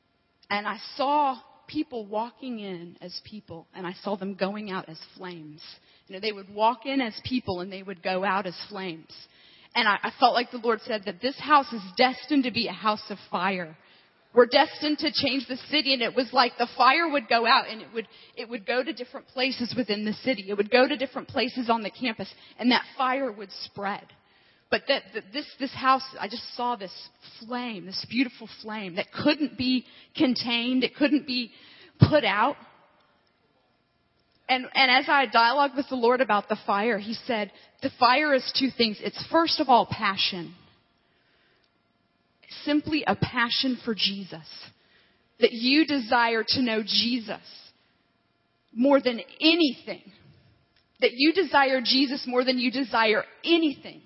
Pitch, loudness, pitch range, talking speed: 245 Hz, -25 LUFS, 205-265 Hz, 180 wpm